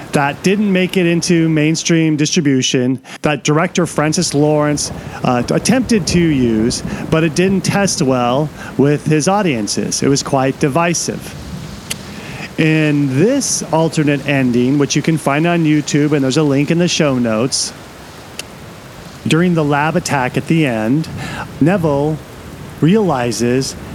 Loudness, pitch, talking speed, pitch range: -14 LUFS, 150 Hz, 135 wpm, 140-170 Hz